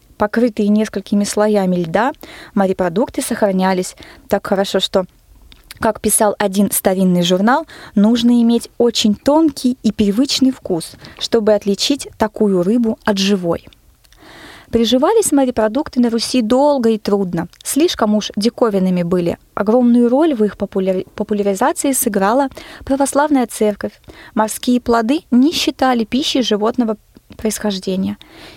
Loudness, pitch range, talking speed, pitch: -16 LUFS, 200-255 Hz, 115 wpm, 220 Hz